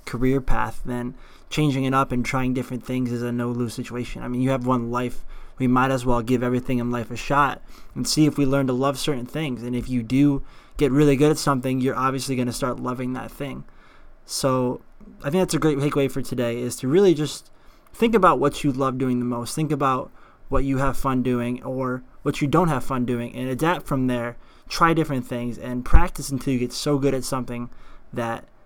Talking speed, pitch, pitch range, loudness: 230 wpm, 130 Hz, 125-140 Hz, -23 LUFS